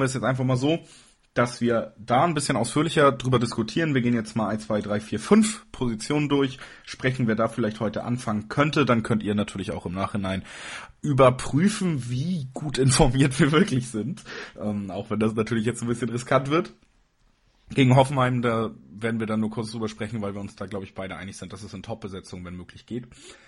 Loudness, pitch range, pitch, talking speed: -24 LUFS, 105-135 Hz, 120 Hz, 205 wpm